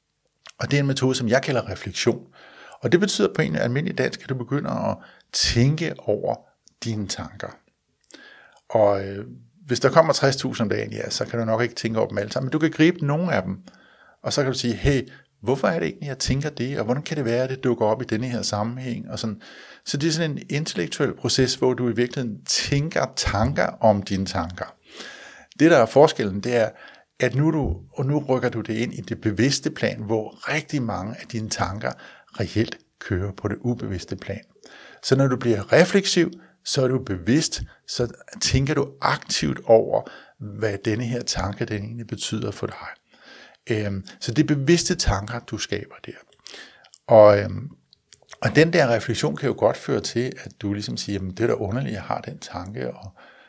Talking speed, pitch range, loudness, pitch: 205 wpm, 110-140 Hz, -23 LUFS, 120 Hz